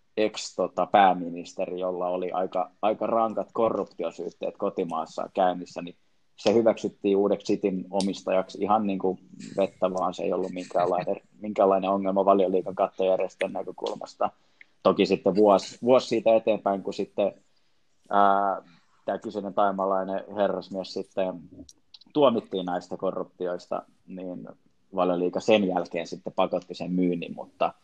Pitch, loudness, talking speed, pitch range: 95 Hz, -26 LUFS, 120 wpm, 90-100 Hz